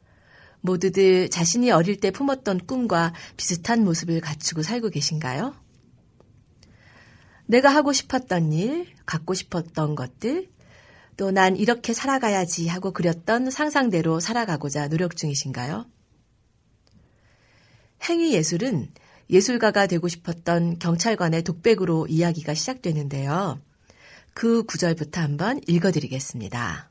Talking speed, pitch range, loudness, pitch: 270 characters per minute, 145-210 Hz, -23 LUFS, 170 Hz